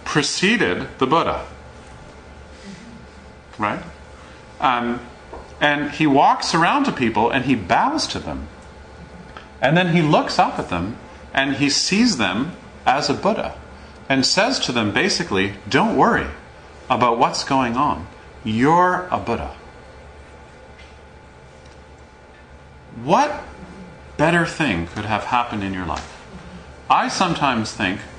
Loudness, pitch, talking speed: -19 LUFS, 90 Hz, 120 wpm